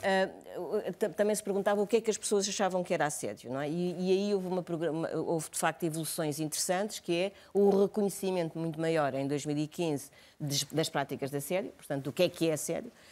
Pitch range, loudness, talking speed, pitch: 155-195 Hz, -32 LUFS, 200 wpm, 175 Hz